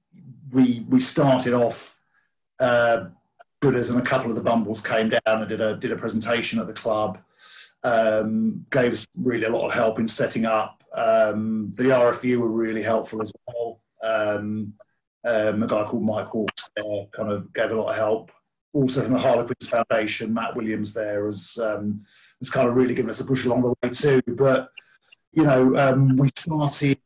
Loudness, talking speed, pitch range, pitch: -23 LUFS, 185 wpm, 110-130 Hz, 115 Hz